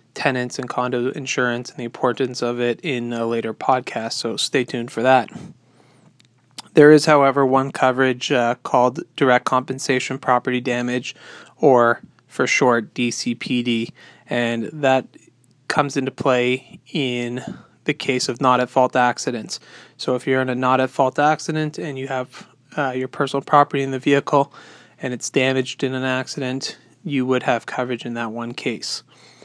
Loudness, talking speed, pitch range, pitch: -20 LUFS, 160 wpm, 125-140 Hz, 130 Hz